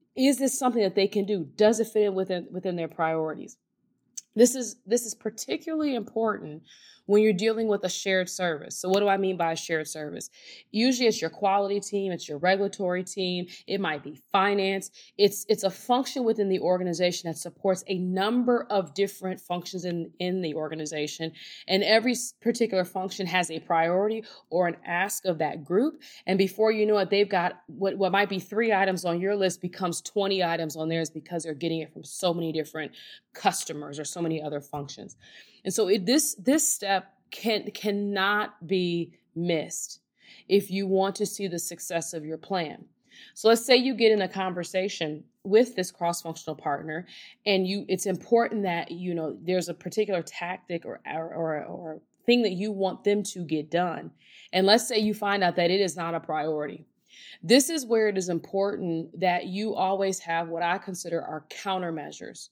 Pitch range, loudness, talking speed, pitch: 170-205 Hz, -27 LUFS, 190 wpm, 190 Hz